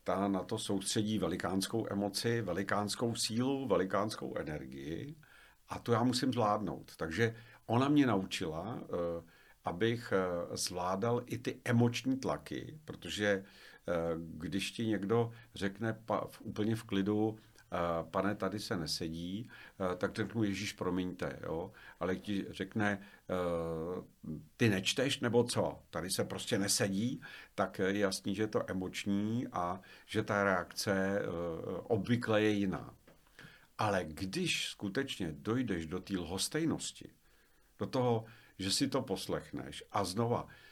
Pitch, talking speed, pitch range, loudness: 100 Hz, 120 wpm, 95-115 Hz, -36 LUFS